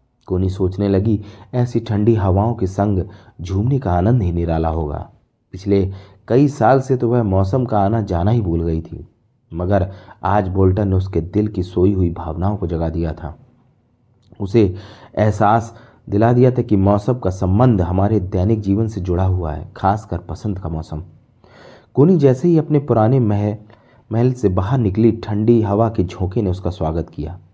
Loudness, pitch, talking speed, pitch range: -18 LUFS, 100 Hz, 175 wpm, 90-115 Hz